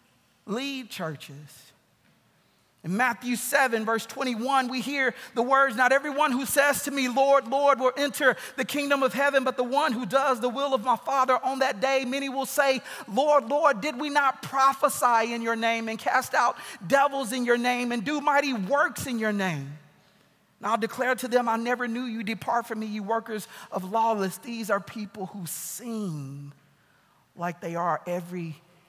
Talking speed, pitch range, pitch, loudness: 185 wpm, 220-270 Hz, 250 Hz, -26 LUFS